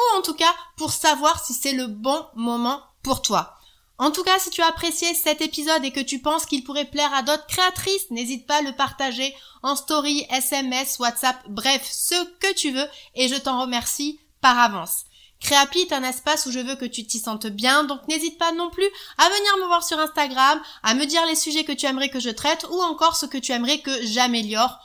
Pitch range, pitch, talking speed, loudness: 255-320 Hz, 285 Hz, 225 wpm, -21 LUFS